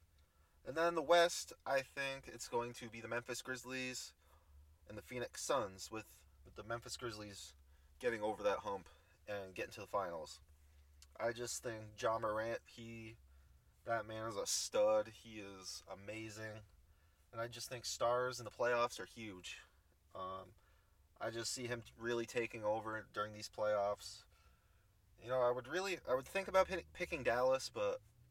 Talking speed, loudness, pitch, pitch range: 165 wpm, -41 LUFS, 110 Hz, 90-120 Hz